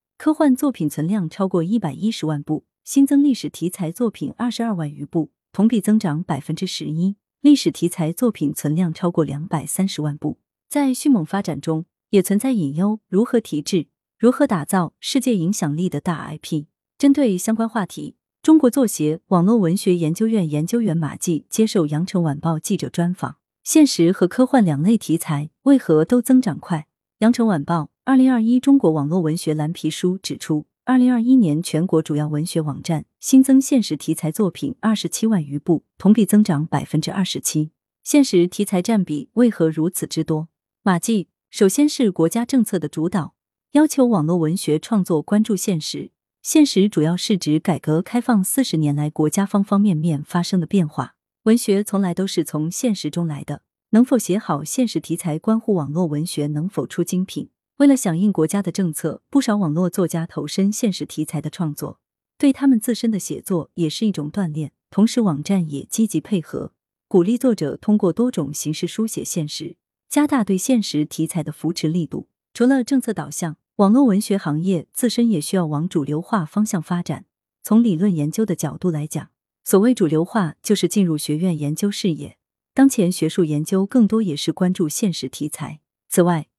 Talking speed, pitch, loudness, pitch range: 290 characters per minute, 180 Hz, -20 LUFS, 155-220 Hz